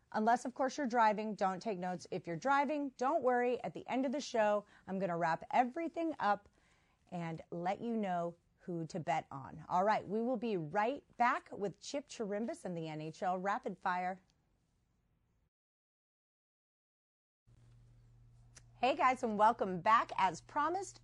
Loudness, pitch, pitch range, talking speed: -36 LUFS, 200 Hz, 170-245 Hz, 155 wpm